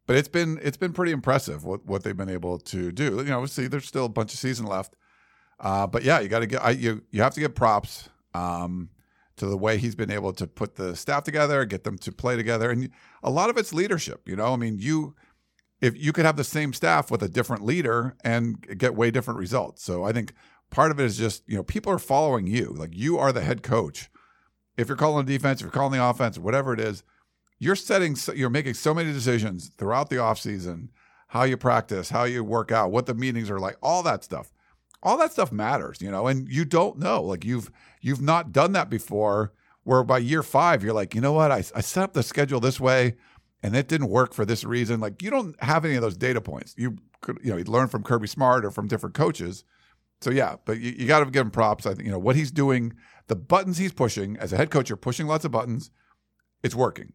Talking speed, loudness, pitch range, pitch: 250 wpm, -25 LUFS, 110-140 Hz, 125 Hz